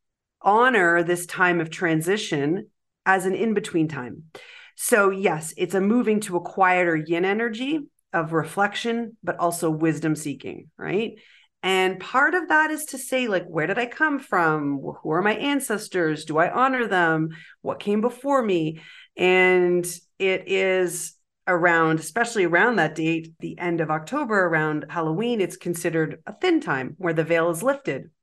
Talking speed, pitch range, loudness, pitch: 160 wpm, 165-215 Hz, -23 LUFS, 180 Hz